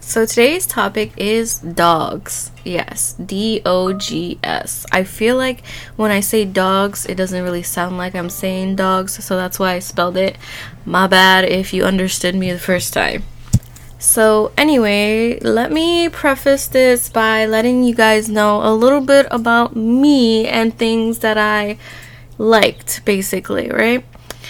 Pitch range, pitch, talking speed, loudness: 185-230 Hz, 210 Hz, 155 wpm, -15 LUFS